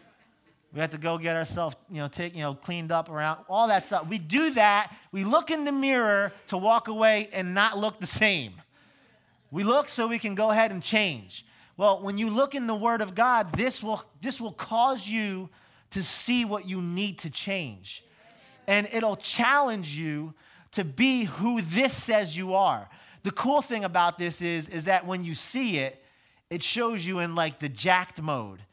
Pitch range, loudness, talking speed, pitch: 165-225 Hz, -26 LUFS, 200 wpm, 195 Hz